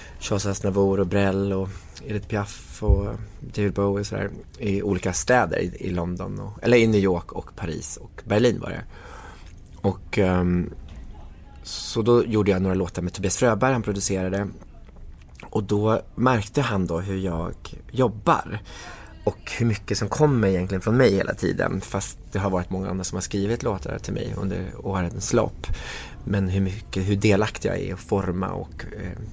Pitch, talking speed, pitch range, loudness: 100 Hz, 175 wpm, 90-105 Hz, -24 LUFS